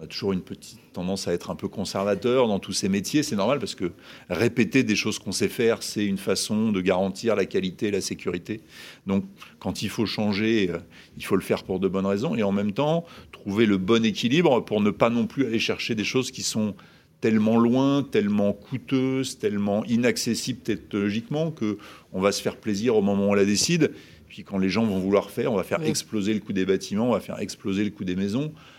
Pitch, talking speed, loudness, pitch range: 105 Hz, 225 wpm, -25 LUFS, 100-115 Hz